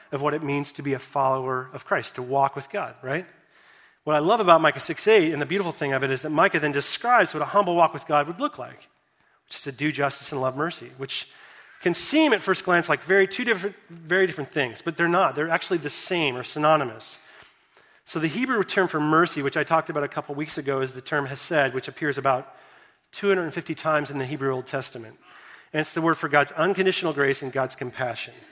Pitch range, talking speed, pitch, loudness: 140-170 Hz, 240 wpm, 150 Hz, -24 LUFS